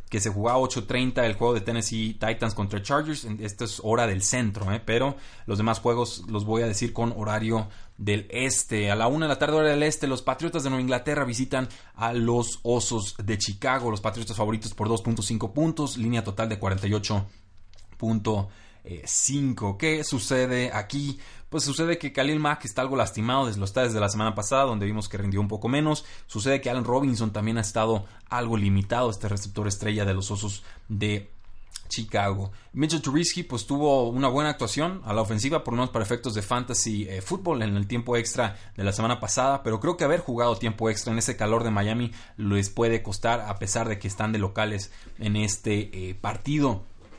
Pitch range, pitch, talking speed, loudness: 105-125 Hz, 115 Hz, 200 wpm, -26 LUFS